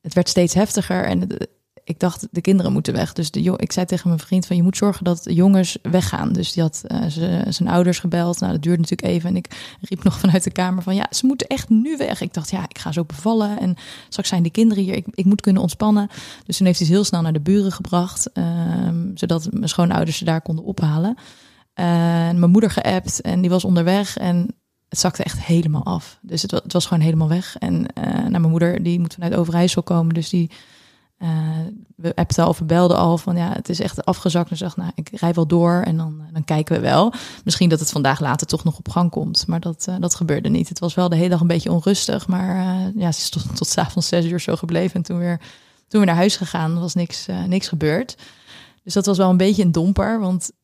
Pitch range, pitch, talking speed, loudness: 170-190 Hz, 180 Hz, 250 wpm, -19 LUFS